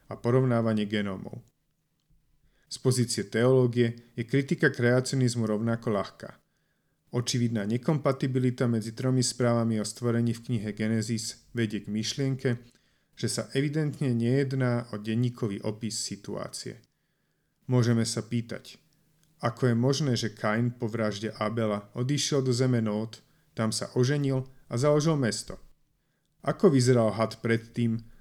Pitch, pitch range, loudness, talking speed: 120 Hz, 115-135 Hz, -28 LUFS, 120 wpm